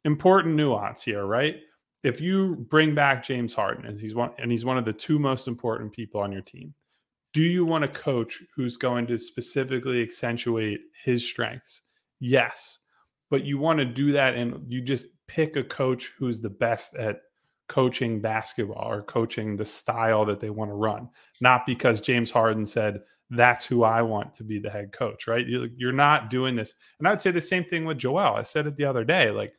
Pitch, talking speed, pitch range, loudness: 125 Hz, 205 wpm, 115-140 Hz, -25 LUFS